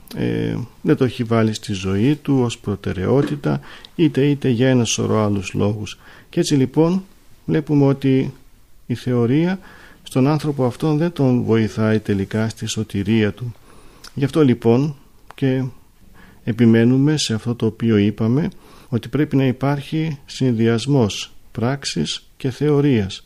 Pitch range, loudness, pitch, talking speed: 110-140 Hz, -19 LUFS, 125 Hz, 135 wpm